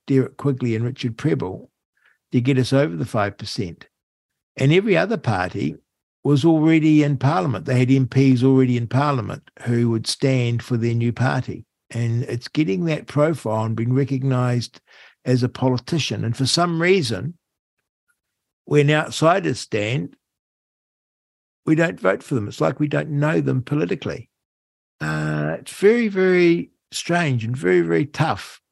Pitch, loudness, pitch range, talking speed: 130 Hz, -20 LUFS, 115-150 Hz, 150 wpm